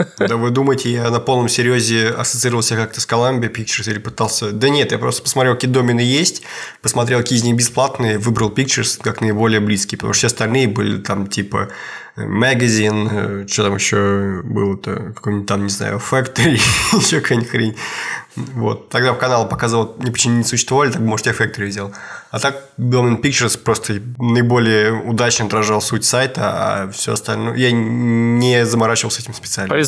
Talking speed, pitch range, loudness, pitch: 170 wpm, 110-125 Hz, -16 LUFS, 115 Hz